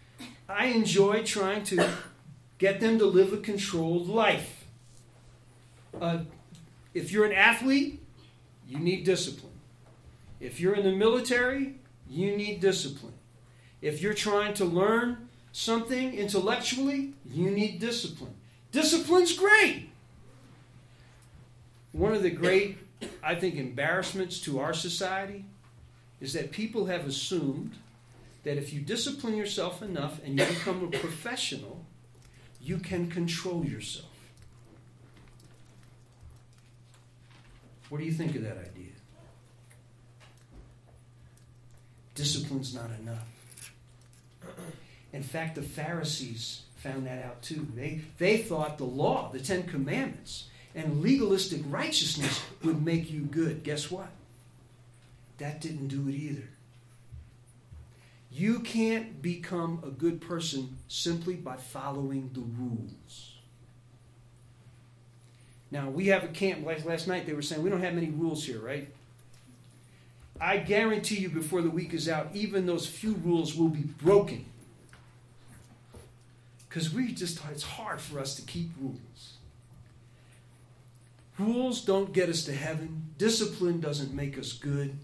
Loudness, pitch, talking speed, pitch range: -30 LUFS, 145 Hz, 125 wpm, 120-180 Hz